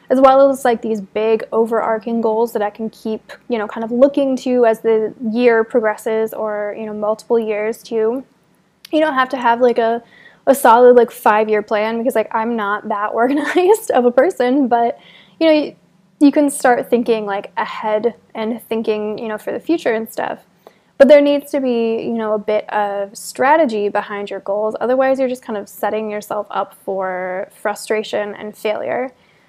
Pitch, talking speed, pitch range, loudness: 225 Hz, 195 wpm, 215-255 Hz, -16 LUFS